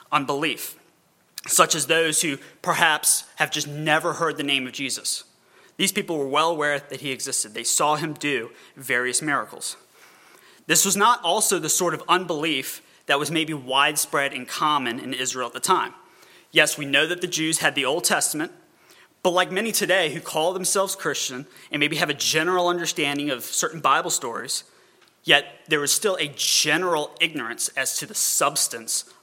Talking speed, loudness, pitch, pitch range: 175 wpm, -22 LUFS, 155 Hz, 140-180 Hz